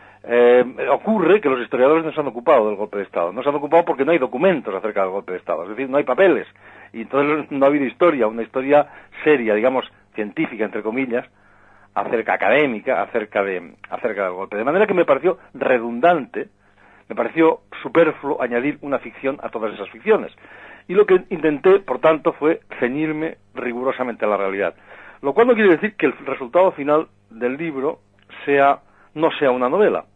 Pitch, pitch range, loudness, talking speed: 135 Hz, 120-160 Hz, -19 LUFS, 190 wpm